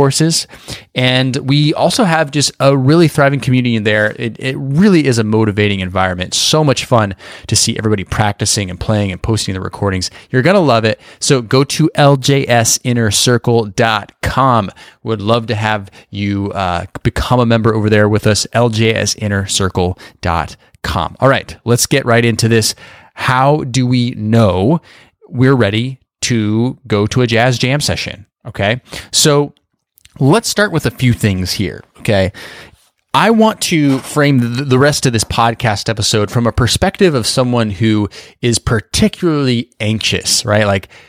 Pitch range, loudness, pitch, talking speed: 105-135 Hz, -13 LUFS, 115 Hz, 155 wpm